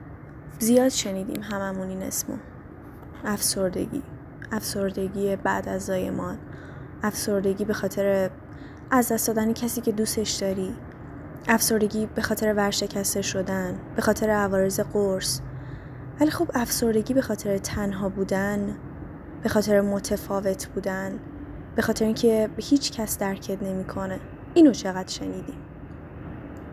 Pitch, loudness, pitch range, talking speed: 200 Hz, -25 LUFS, 190-220 Hz, 110 wpm